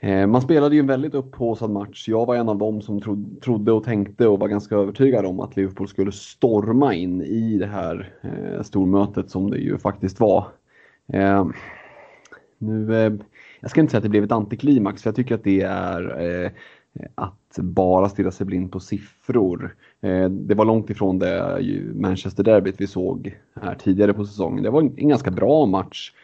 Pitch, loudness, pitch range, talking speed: 100 Hz, -21 LUFS, 95-115 Hz, 175 wpm